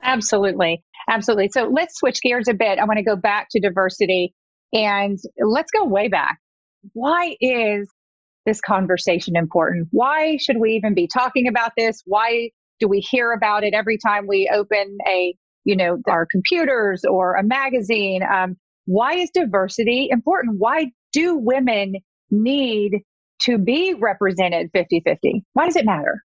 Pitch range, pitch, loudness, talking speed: 195-250 Hz, 215 Hz, -19 LUFS, 160 wpm